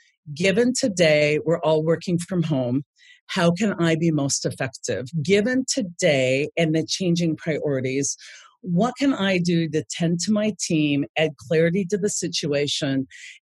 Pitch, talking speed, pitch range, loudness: 165 Hz, 145 wpm, 150-195 Hz, -22 LUFS